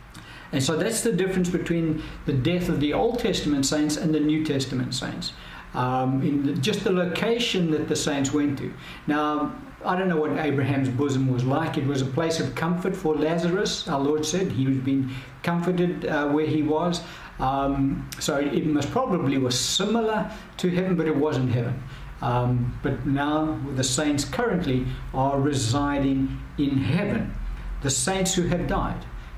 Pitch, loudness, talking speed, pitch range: 150 Hz, -25 LUFS, 175 wpm, 135-170 Hz